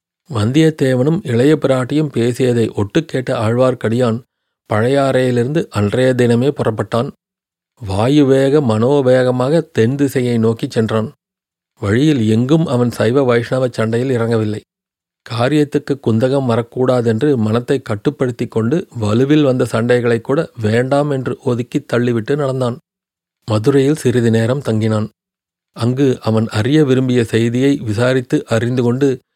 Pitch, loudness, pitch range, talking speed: 125 Hz, -15 LUFS, 115-140 Hz, 105 wpm